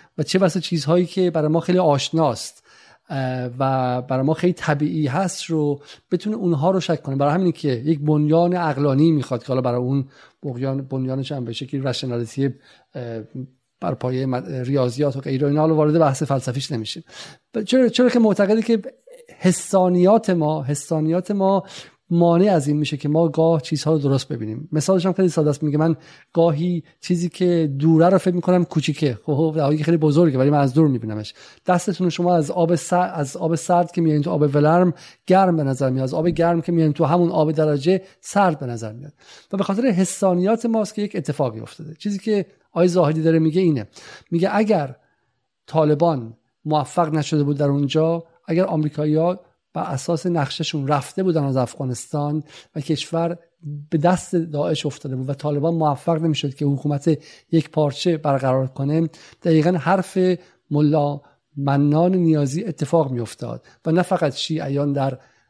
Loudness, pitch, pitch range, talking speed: -20 LUFS, 155 Hz, 140-175 Hz, 170 wpm